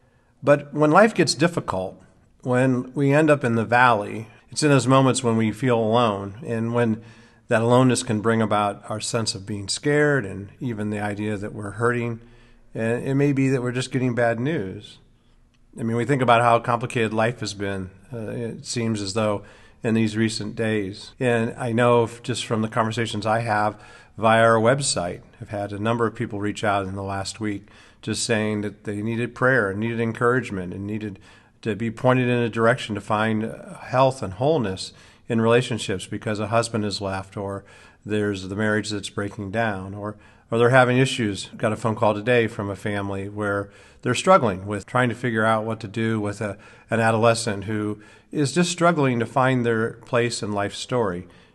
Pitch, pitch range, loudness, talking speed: 115 Hz, 105-120 Hz, -22 LUFS, 195 wpm